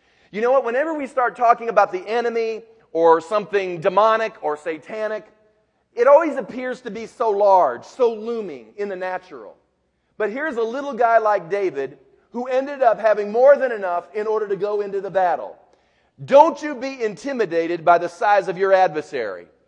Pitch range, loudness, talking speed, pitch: 200-260 Hz, -20 LUFS, 175 wpm, 220 Hz